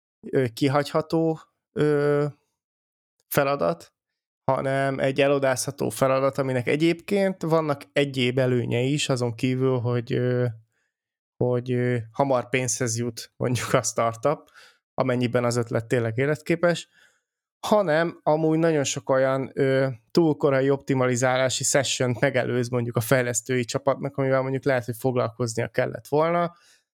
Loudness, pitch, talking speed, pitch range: -24 LUFS, 135 Hz, 105 wpm, 125-145 Hz